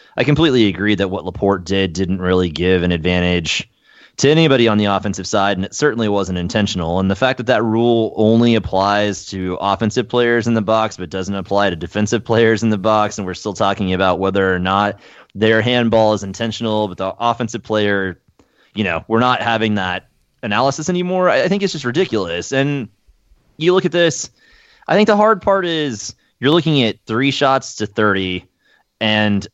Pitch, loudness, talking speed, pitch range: 105 Hz, -16 LUFS, 190 wpm, 95-125 Hz